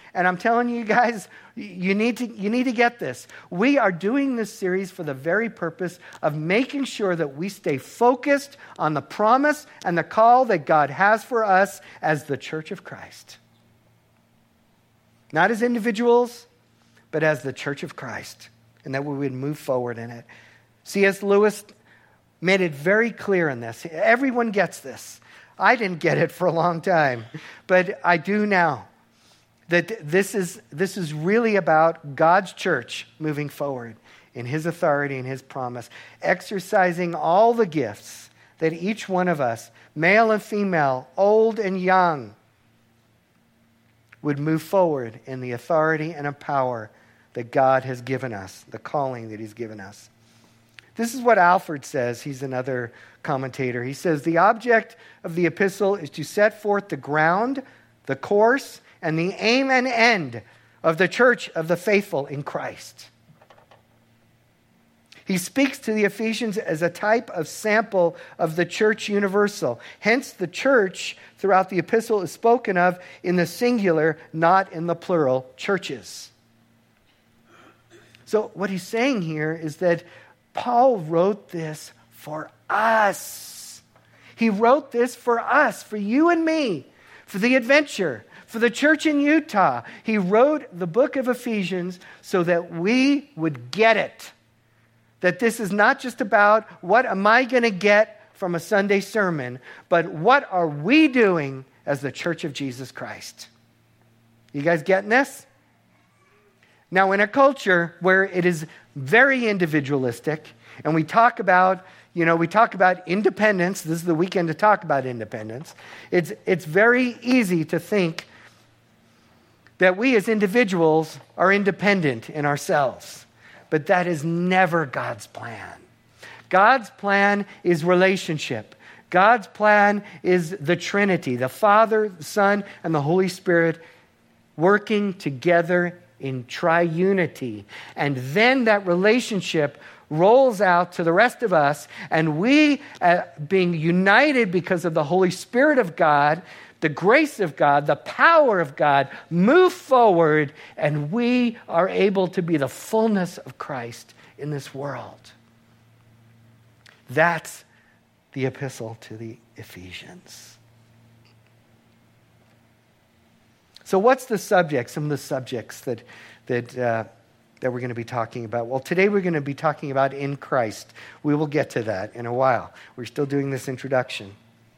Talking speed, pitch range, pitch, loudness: 150 wpm, 130-210 Hz, 170 Hz, -21 LUFS